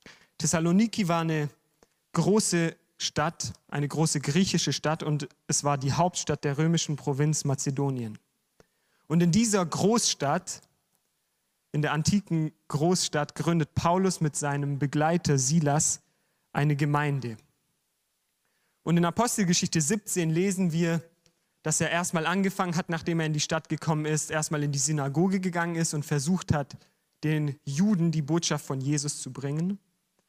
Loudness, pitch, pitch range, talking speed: -27 LUFS, 160 Hz, 150-175 Hz, 135 wpm